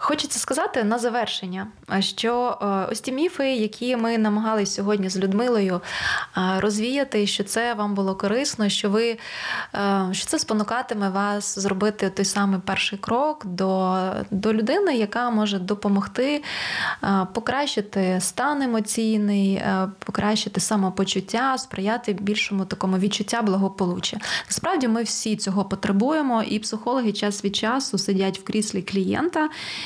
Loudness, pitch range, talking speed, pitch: -23 LUFS, 195-235 Hz, 125 wpm, 210 Hz